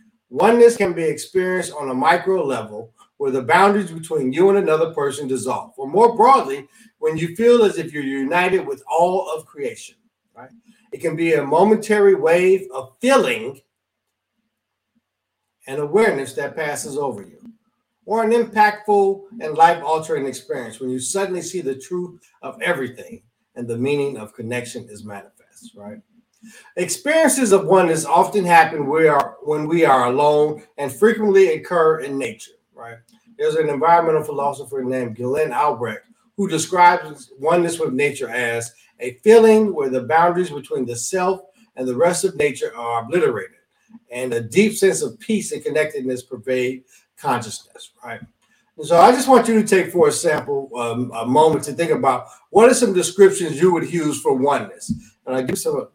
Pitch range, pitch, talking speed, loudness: 140-220 Hz, 175 Hz, 165 wpm, -18 LUFS